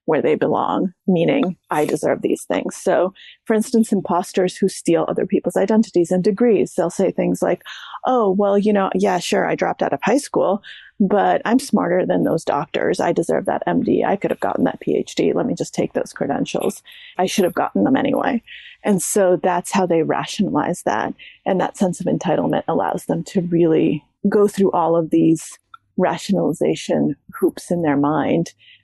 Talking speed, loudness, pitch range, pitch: 185 wpm, -19 LUFS, 175-220 Hz, 195 Hz